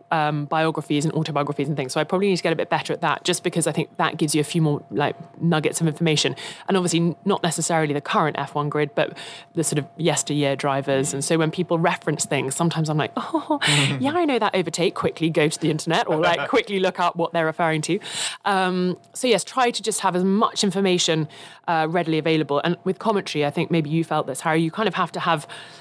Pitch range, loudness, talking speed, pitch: 150-180 Hz, -22 LUFS, 240 wpm, 165 Hz